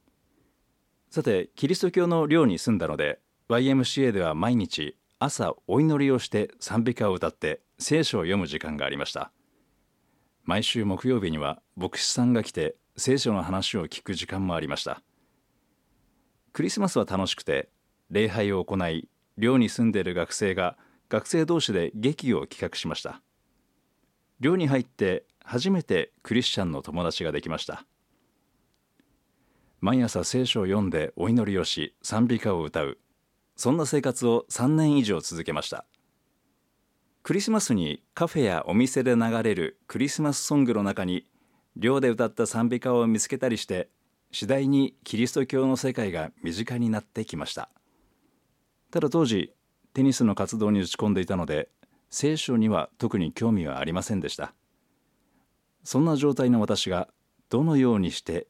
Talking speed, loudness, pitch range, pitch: 295 characters per minute, -26 LUFS, 100-135 Hz, 120 Hz